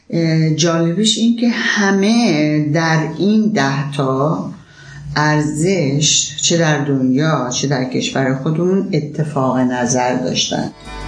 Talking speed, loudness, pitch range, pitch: 100 wpm, -15 LUFS, 140-170 Hz, 150 Hz